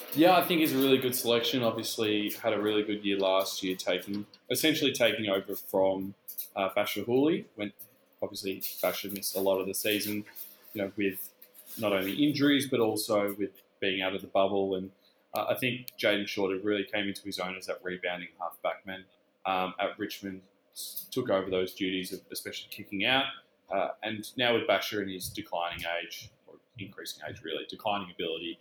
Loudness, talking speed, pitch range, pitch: -30 LUFS, 185 wpm, 95-110 Hz, 100 Hz